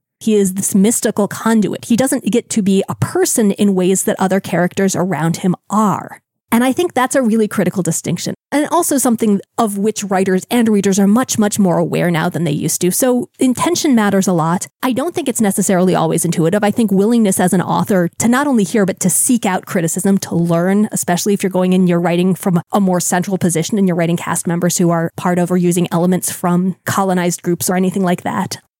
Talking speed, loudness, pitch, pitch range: 220 wpm, -15 LUFS, 190 Hz, 175-215 Hz